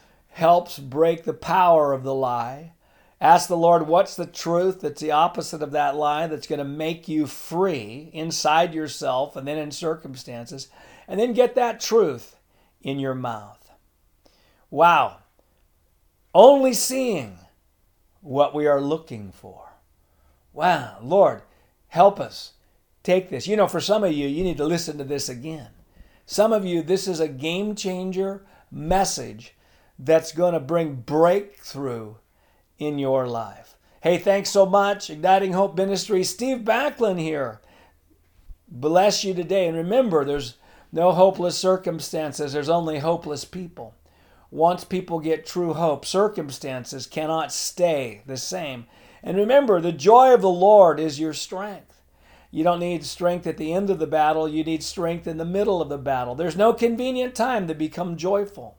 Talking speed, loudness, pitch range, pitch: 155 wpm, -22 LUFS, 135-185 Hz, 160 Hz